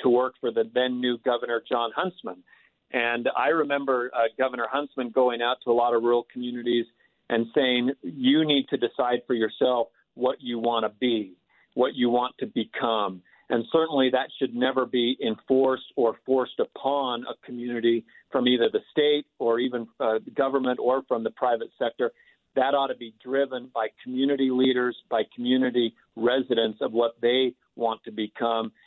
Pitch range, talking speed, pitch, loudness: 120-130 Hz, 175 wpm, 125 Hz, -26 LUFS